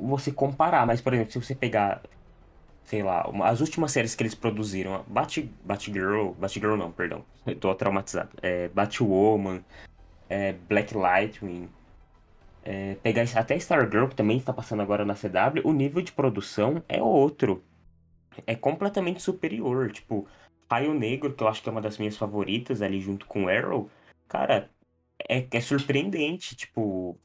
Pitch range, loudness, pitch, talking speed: 95-130 Hz, -27 LUFS, 105 Hz, 155 wpm